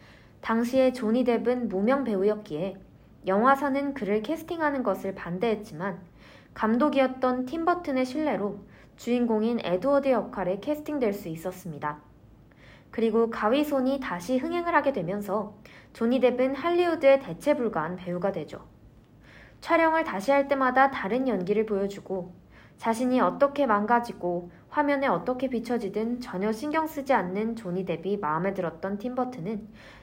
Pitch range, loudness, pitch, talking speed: 190-270 Hz, -27 LUFS, 225 Hz, 320 characters per minute